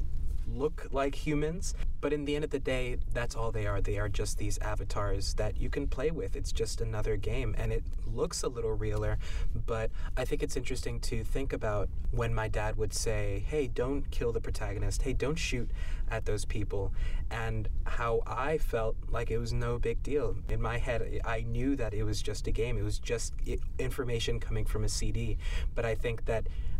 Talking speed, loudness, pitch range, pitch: 205 wpm, -34 LUFS, 100-115 Hz, 110 Hz